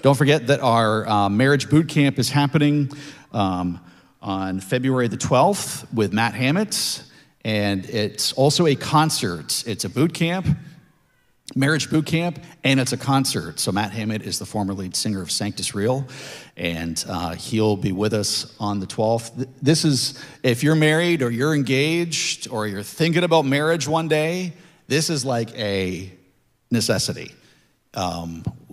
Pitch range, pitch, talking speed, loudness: 105-155 Hz, 130 Hz, 155 wpm, -21 LUFS